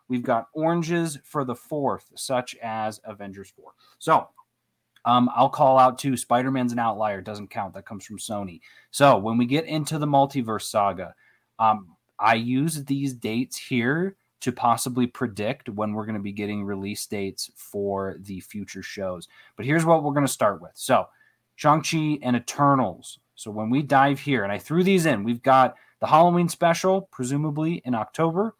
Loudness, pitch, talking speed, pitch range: -24 LUFS, 125 Hz, 180 wpm, 105-145 Hz